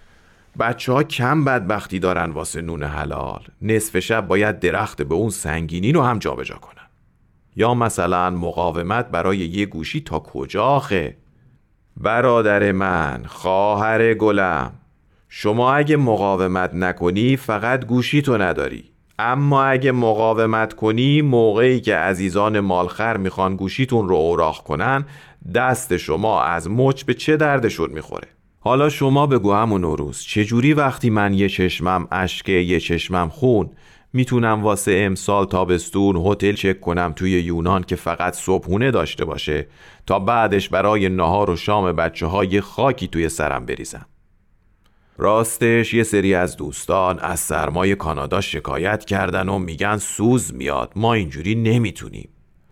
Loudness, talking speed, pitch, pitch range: -19 LUFS, 135 wpm, 100 Hz, 90-115 Hz